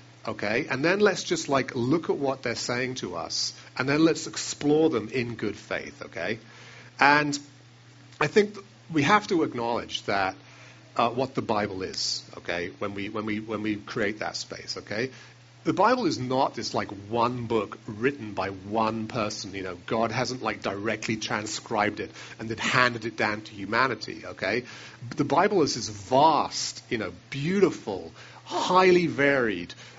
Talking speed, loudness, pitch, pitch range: 170 wpm, -27 LUFS, 120 Hz, 110-135 Hz